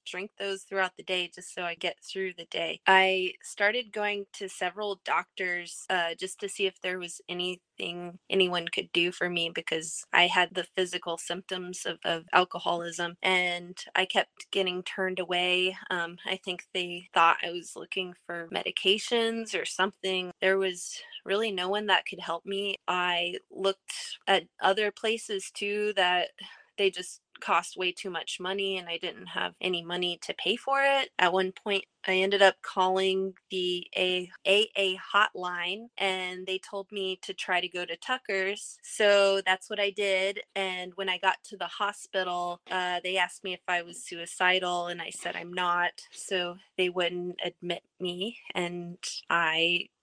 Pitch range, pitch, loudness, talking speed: 175-195 Hz, 185 Hz, -29 LUFS, 175 wpm